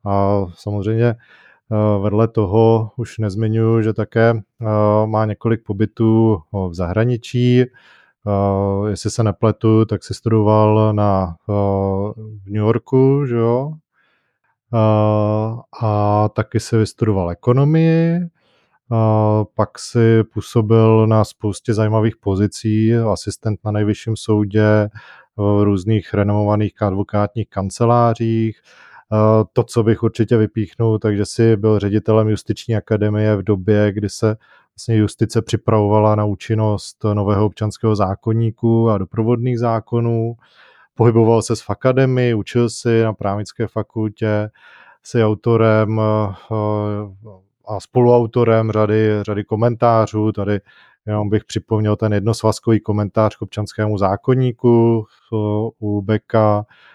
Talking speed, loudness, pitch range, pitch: 105 wpm, -17 LUFS, 105-115 Hz, 110 Hz